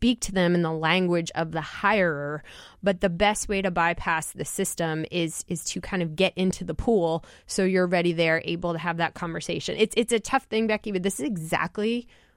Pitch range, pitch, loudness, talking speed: 165-200 Hz, 175 Hz, -26 LUFS, 220 wpm